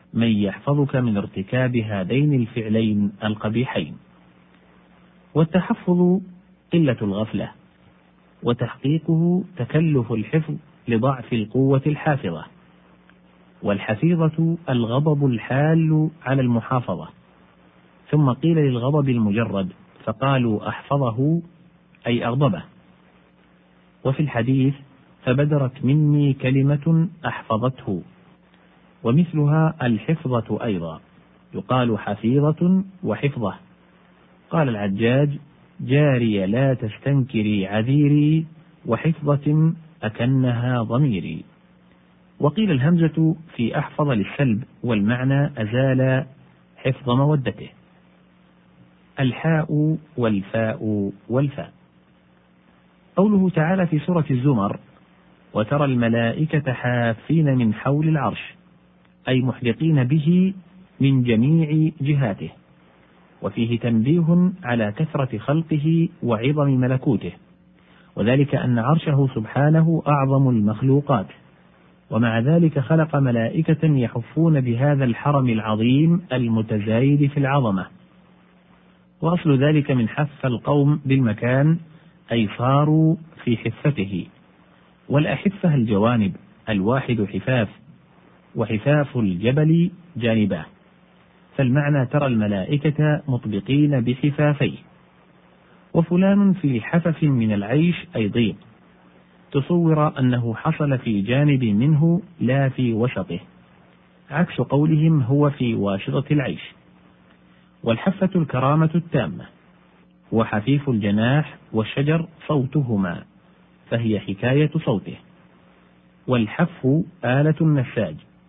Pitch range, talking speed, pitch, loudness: 110-155 Hz, 80 wpm, 130 Hz, -21 LUFS